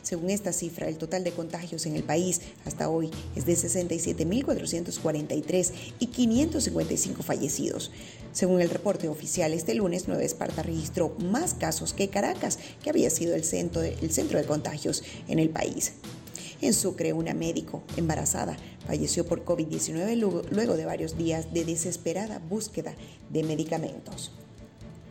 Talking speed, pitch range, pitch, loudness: 140 wpm, 155-180 Hz, 170 Hz, -29 LUFS